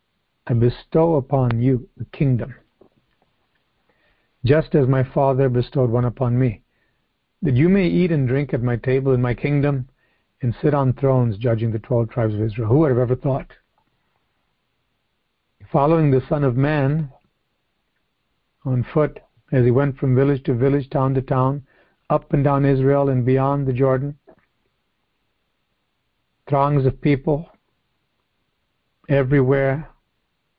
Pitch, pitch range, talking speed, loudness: 135 Hz, 125-145 Hz, 135 wpm, -19 LUFS